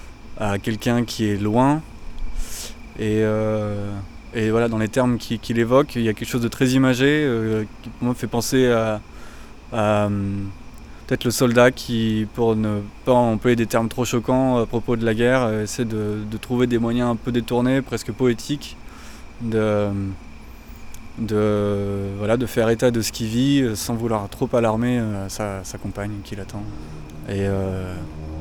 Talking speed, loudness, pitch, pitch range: 165 wpm, -21 LUFS, 110 Hz, 105-120 Hz